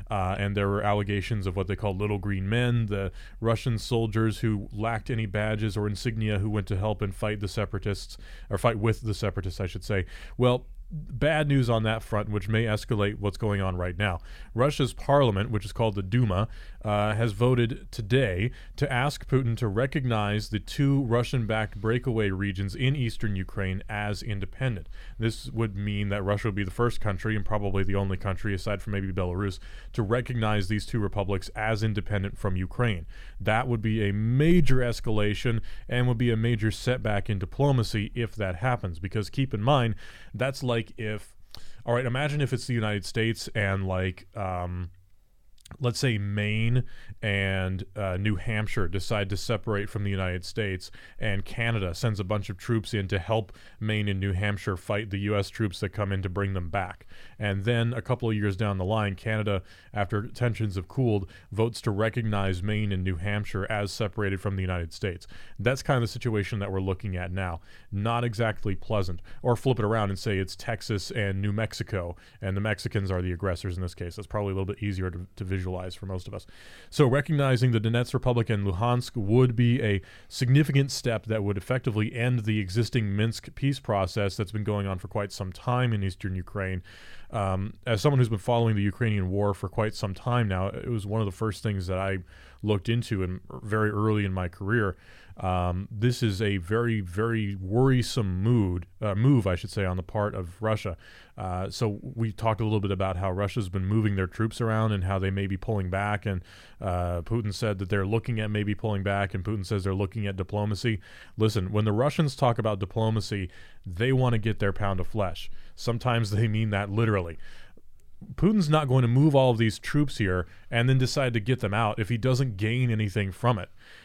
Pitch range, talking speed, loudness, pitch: 100-115 Hz, 205 wpm, -28 LUFS, 105 Hz